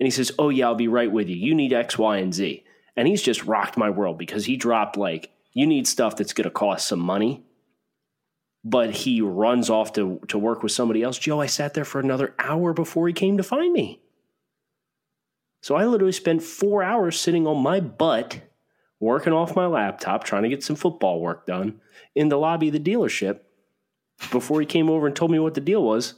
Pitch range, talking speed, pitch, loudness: 120-170 Hz, 220 wpm, 150 Hz, -23 LUFS